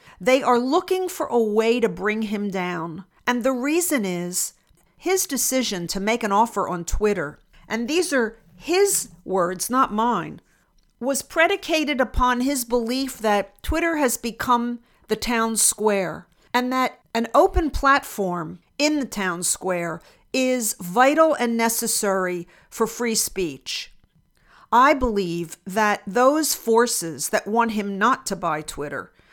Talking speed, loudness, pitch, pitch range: 140 wpm, -22 LUFS, 230 Hz, 195-260 Hz